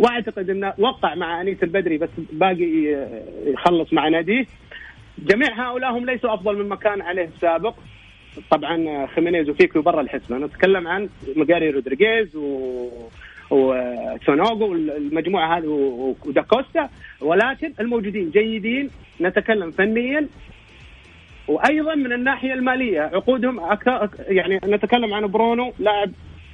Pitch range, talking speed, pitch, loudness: 155-225 Hz, 120 wpm, 190 Hz, -20 LUFS